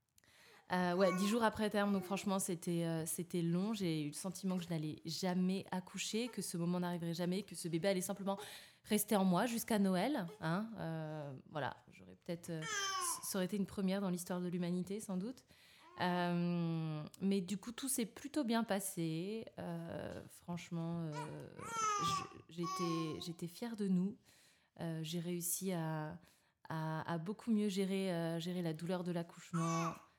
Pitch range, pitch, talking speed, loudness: 170-200 Hz, 180 Hz, 165 wpm, -40 LUFS